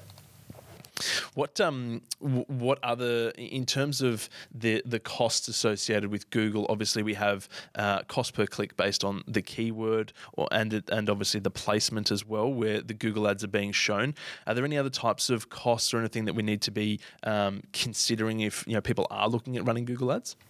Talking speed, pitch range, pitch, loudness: 190 wpm, 105-120 Hz, 110 Hz, -29 LUFS